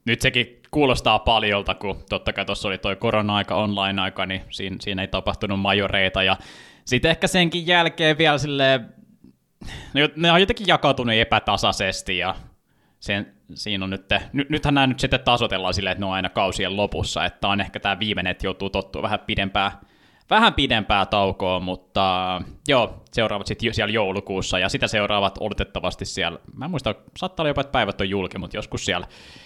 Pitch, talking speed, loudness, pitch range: 100 Hz, 165 wpm, -21 LUFS, 95-125 Hz